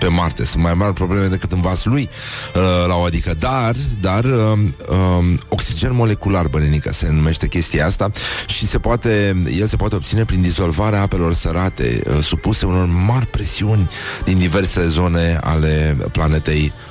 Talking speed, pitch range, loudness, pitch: 150 wpm, 85-105 Hz, -17 LUFS, 90 Hz